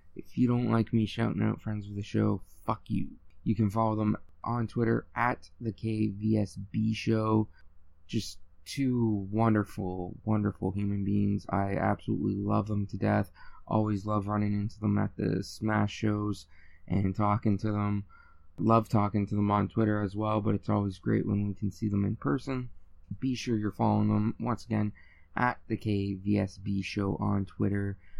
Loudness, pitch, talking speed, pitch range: -31 LUFS, 105 Hz, 170 wpm, 100-110 Hz